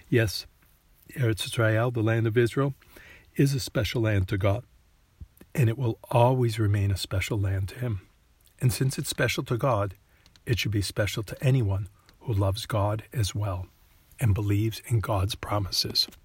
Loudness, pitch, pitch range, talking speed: -27 LUFS, 110 Hz, 95-120 Hz, 165 wpm